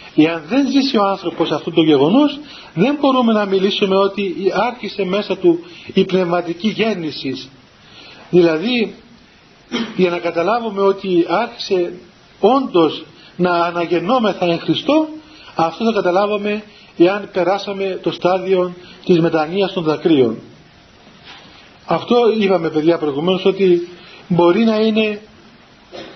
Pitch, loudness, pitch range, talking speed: 190 Hz, -16 LUFS, 175-215 Hz, 110 wpm